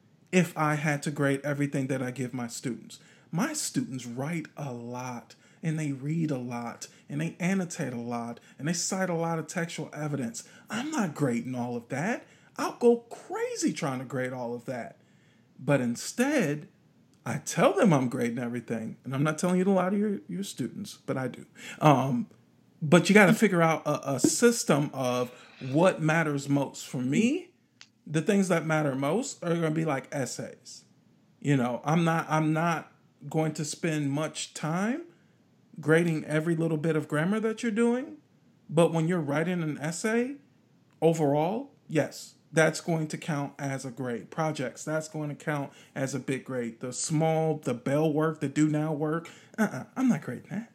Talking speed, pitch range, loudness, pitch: 185 wpm, 140-180 Hz, -29 LUFS, 155 Hz